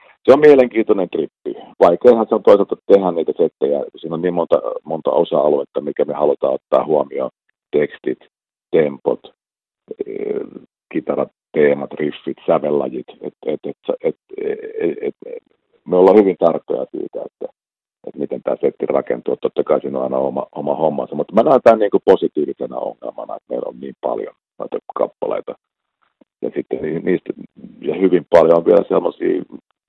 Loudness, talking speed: -17 LUFS, 155 wpm